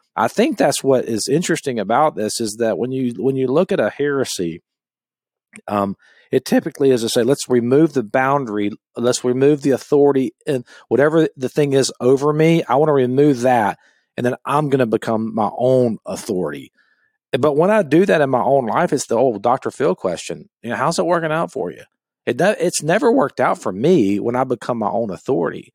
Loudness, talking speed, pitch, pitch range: -18 LUFS, 205 wpm, 130 Hz, 120-150 Hz